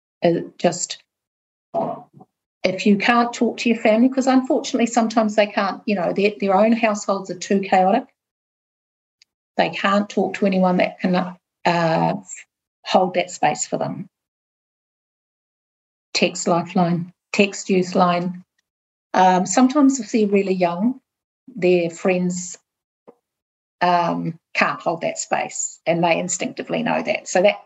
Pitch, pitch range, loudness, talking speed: 190 Hz, 175-220 Hz, -20 LUFS, 130 wpm